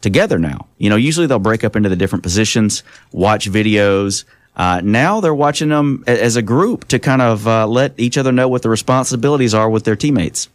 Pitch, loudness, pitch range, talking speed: 115 Hz, -14 LUFS, 105-130 Hz, 210 wpm